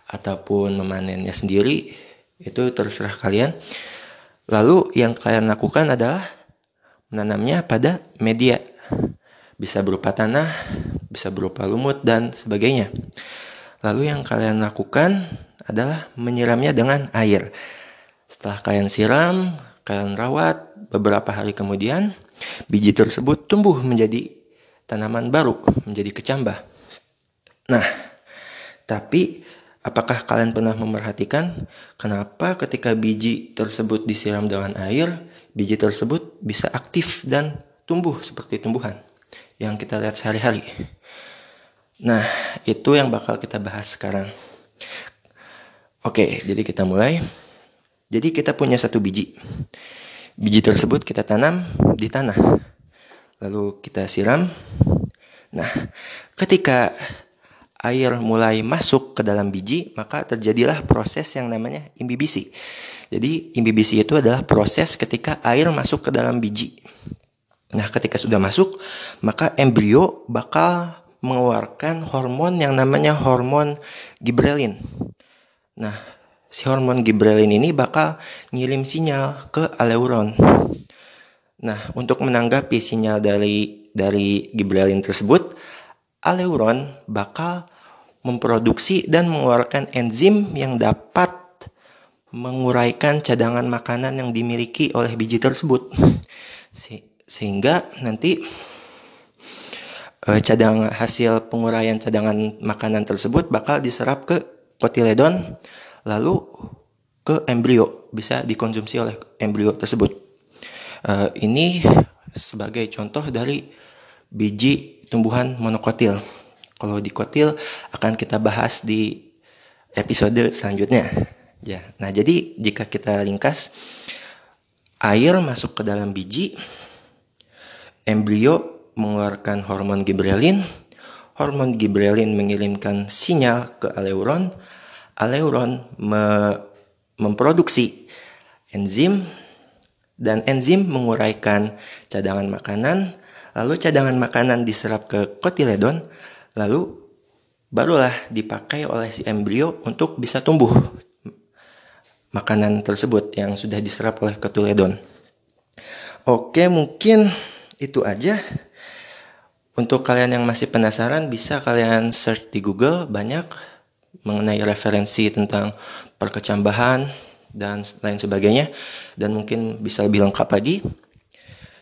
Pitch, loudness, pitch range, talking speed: 115 Hz, -20 LUFS, 105-130 Hz, 100 wpm